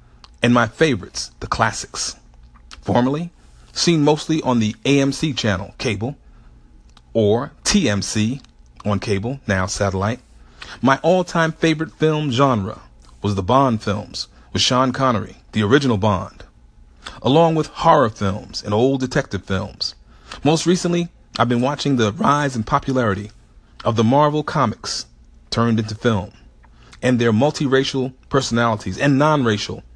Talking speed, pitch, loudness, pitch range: 130 wpm, 115 Hz, -19 LUFS, 100-140 Hz